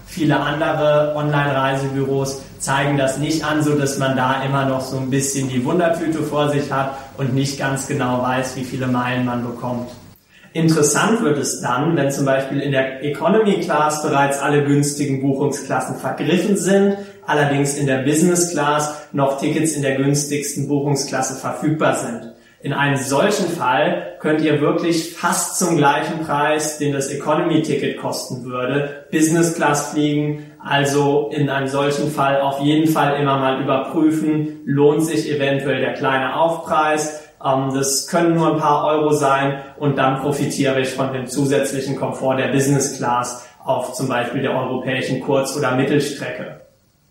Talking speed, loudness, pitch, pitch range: 155 wpm, -18 LUFS, 140 Hz, 135-150 Hz